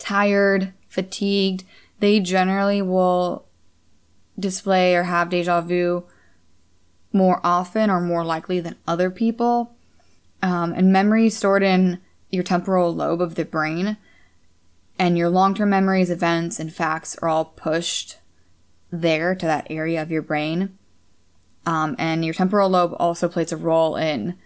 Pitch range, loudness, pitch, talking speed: 160-190 Hz, -21 LUFS, 175 Hz, 135 wpm